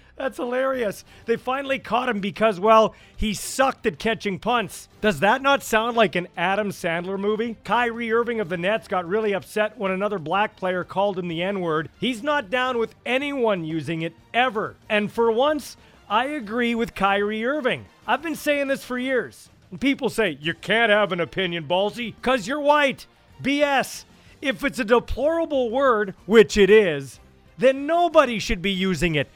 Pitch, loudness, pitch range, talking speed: 220 Hz, -22 LUFS, 195-255 Hz, 180 wpm